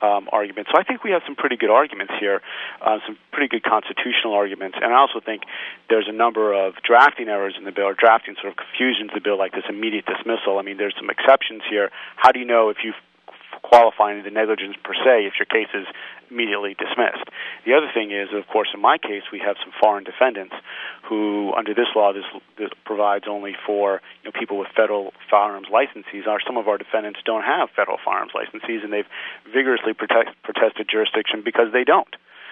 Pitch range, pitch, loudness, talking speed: 100-110 Hz, 105 Hz, -20 LUFS, 210 wpm